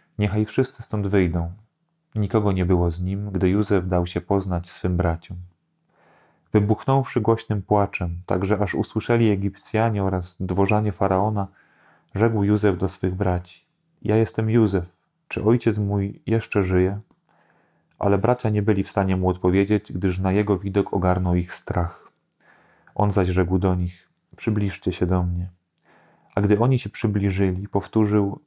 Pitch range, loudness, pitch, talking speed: 90-110 Hz, -23 LUFS, 100 Hz, 145 wpm